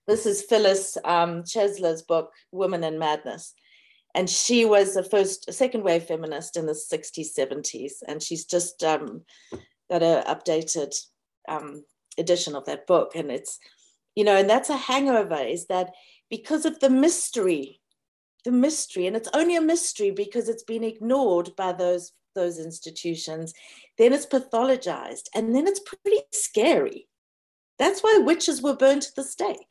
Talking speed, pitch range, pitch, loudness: 160 wpm, 170-275 Hz, 210 Hz, -24 LUFS